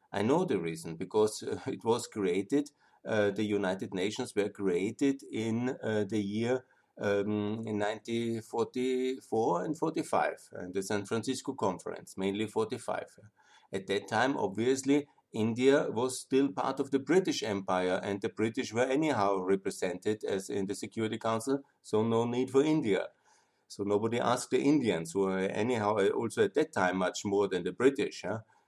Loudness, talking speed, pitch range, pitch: -32 LUFS, 160 wpm, 100-130 Hz, 110 Hz